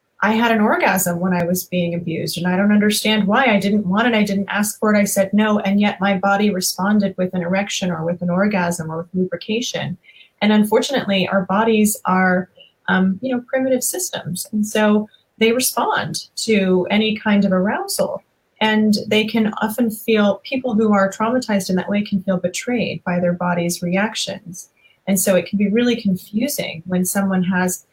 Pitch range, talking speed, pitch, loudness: 185-215 Hz, 190 wpm, 200 Hz, -18 LUFS